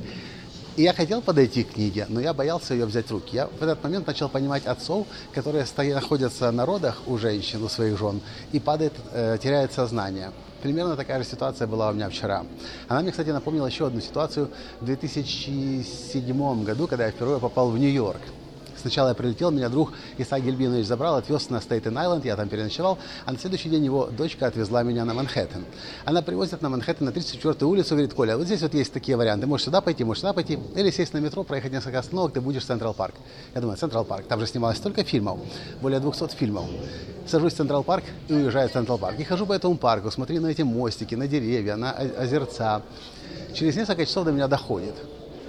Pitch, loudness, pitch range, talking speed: 135 Hz, -26 LUFS, 120-155 Hz, 205 wpm